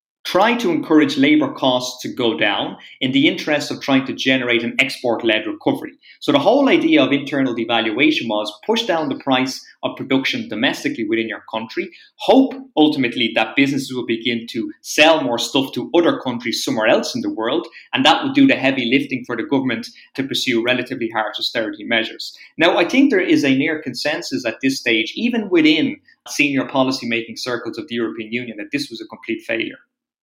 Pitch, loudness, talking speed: 140 Hz, -18 LUFS, 195 wpm